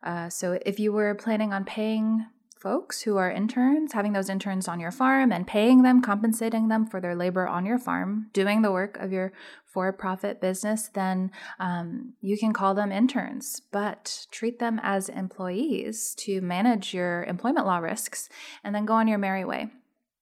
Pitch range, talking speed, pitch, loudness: 190-230 Hz, 185 wpm, 210 Hz, -26 LUFS